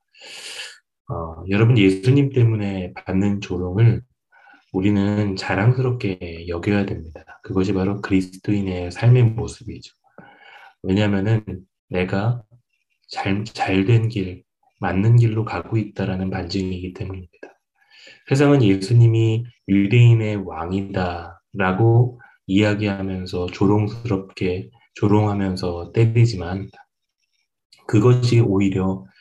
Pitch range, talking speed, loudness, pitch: 95-115 Hz, 240 characters per minute, -20 LUFS, 100 Hz